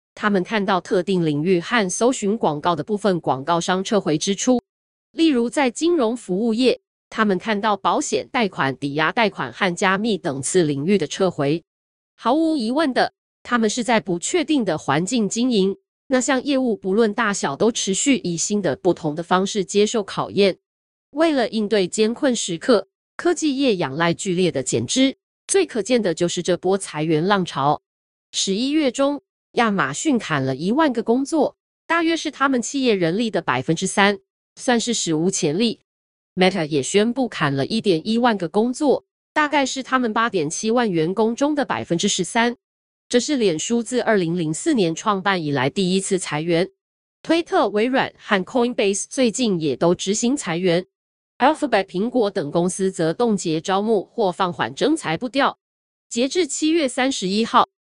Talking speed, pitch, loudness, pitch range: 275 characters per minute, 210 Hz, -20 LUFS, 180-250 Hz